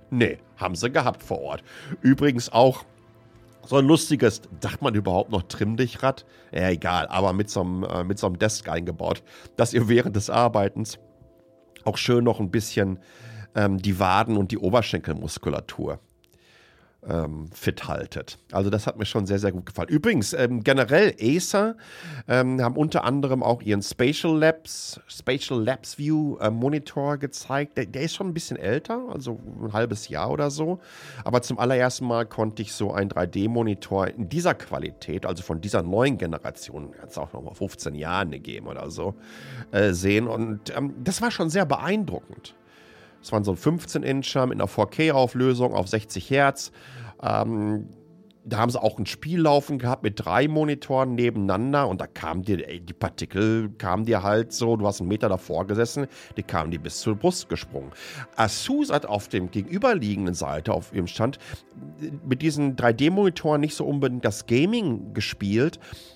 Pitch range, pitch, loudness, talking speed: 100-135 Hz, 115 Hz, -25 LUFS, 170 wpm